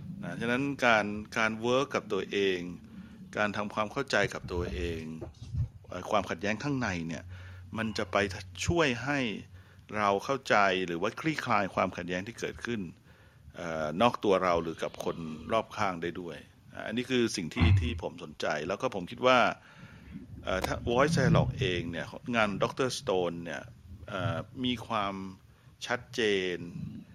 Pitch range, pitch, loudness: 90-120 Hz, 105 Hz, -31 LUFS